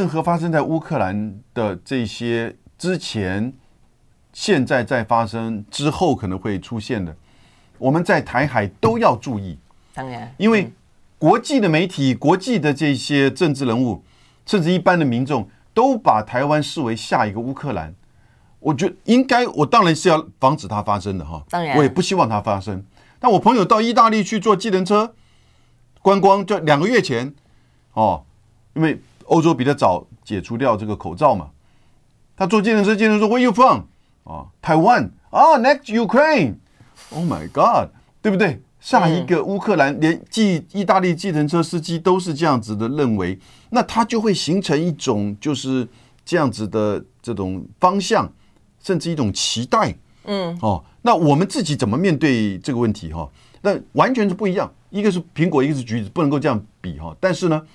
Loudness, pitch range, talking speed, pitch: -18 LUFS, 115-190 Hz, 295 characters per minute, 145 Hz